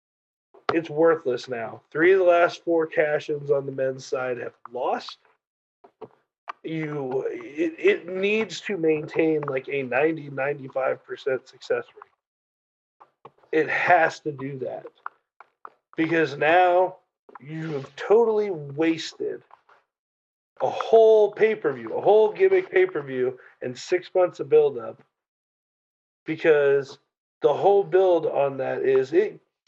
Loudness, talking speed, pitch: -23 LUFS, 120 wpm, 180 Hz